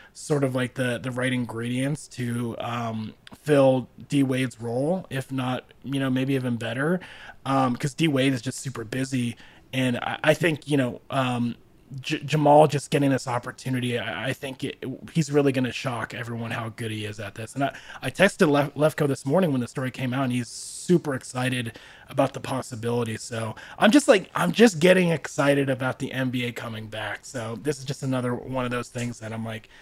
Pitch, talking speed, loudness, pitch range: 130 Hz, 205 wpm, -25 LUFS, 120-140 Hz